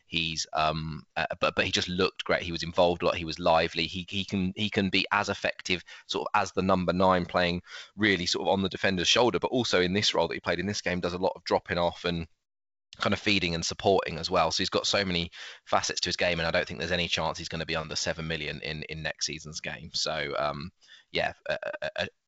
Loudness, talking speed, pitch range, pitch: -28 LUFS, 265 wpm, 80-95 Hz, 90 Hz